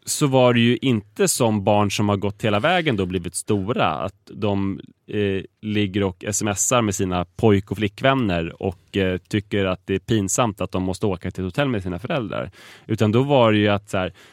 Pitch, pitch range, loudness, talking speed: 105 Hz, 95-110 Hz, -21 LUFS, 215 wpm